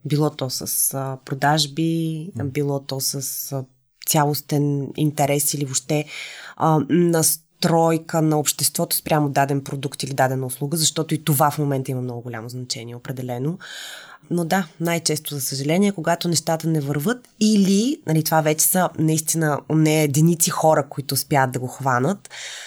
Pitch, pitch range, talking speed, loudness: 150 Hz, 140-160 Hz, 140 wpm, -21 LUFS